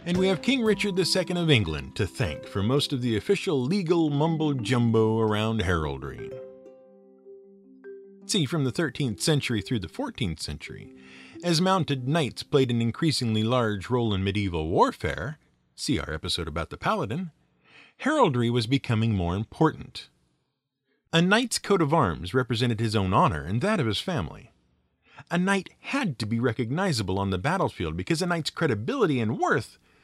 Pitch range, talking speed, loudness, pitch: 105-165 Hz, 160 wpm, -26 LUFS, 130 Hz